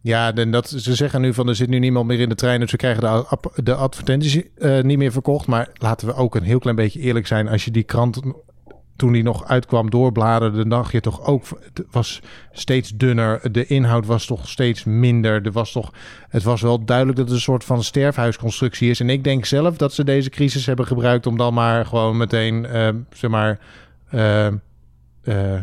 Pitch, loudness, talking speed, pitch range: 120 Hz, -19 LUFS, 220 wpm, 115-130 Hz